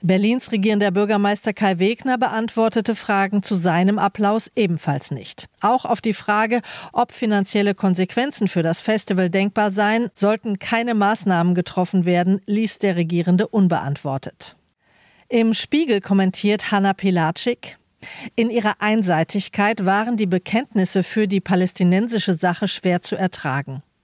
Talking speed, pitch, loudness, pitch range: 125 wpm, 200 Hz, -20 LUFS, 185-220 Hz